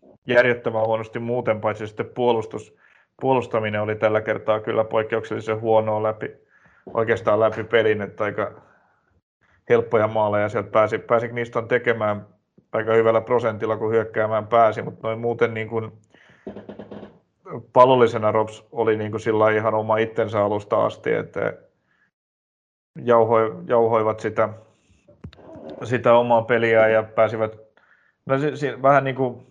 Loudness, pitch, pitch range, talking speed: -21 LUFS, 110 Hz, 110-120 Hz, 120 wpm